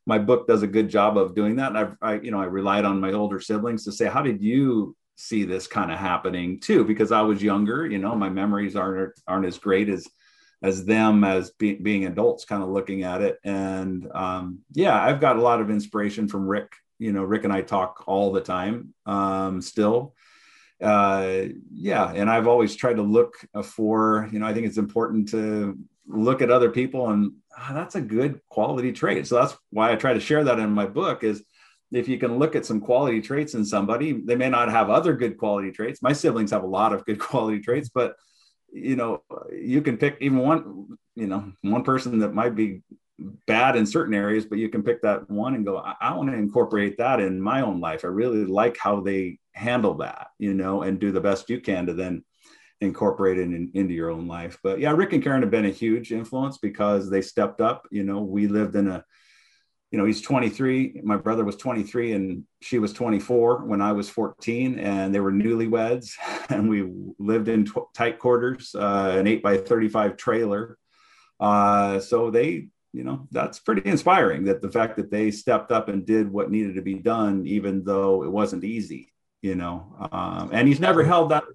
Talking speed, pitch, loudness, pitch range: 215 wpm, 105 Hz, -23 LUFS, 95-115 Hz